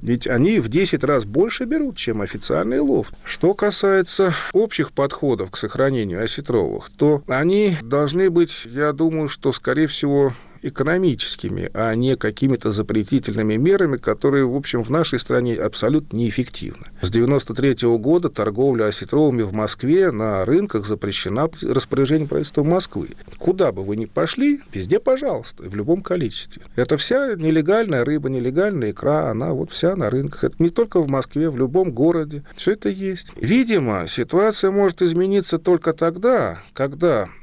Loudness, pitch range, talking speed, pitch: -20 LUFS, 120-180 Hz, 150 wpm, 150 Hz